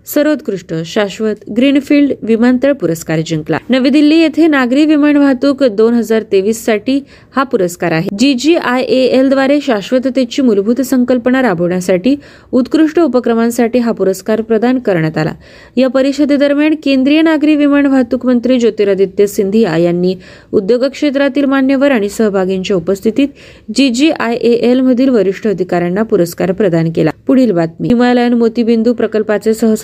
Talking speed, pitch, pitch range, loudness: 115 wpm, 245 Hz, 205-275 Hz, -12 LUFS